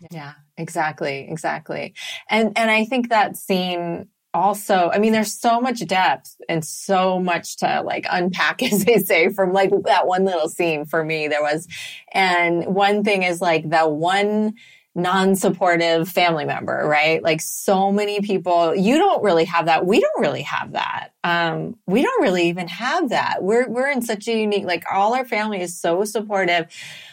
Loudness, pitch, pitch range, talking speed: -19 LUFS, 185 Hz, 170-210 Hz, 175 wpm